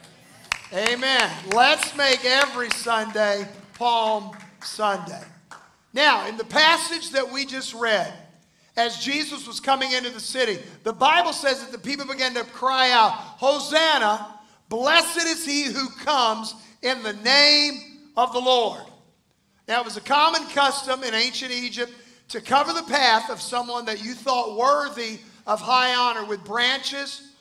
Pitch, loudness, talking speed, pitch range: 250 Hz, -21 LUFS, 150 wpm, 225-275 Hz